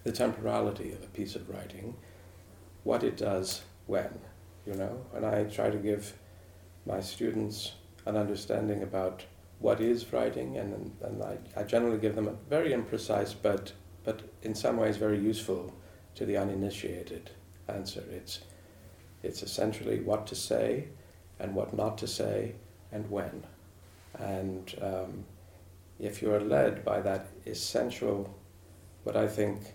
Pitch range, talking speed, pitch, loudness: 90-105 Hz, 145 wpm, 95 Hz, -33 LUFS